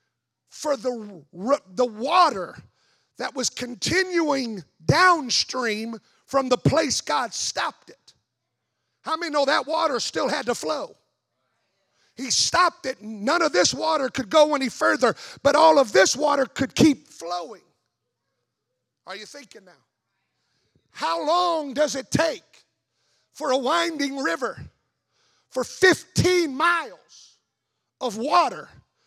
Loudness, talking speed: -22 LUFS, 125 wpm